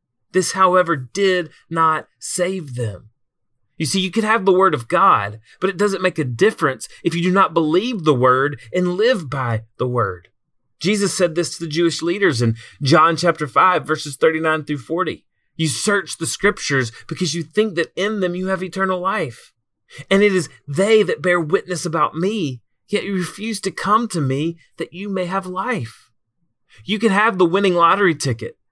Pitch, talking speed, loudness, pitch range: 170 Hz, 190 wpm, -19 LUFS, 145-190 Hz